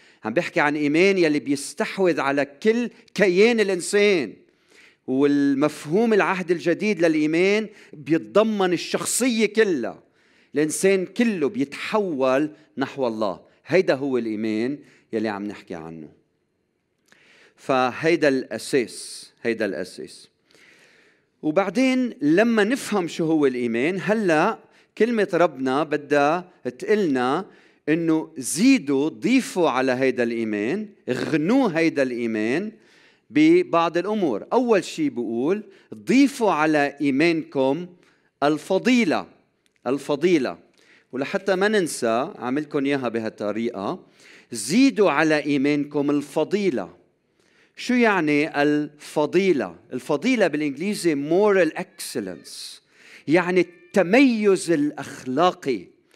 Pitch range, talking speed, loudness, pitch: 140-200 Hz, 90 wpm, -22 LUFS, 165 Hz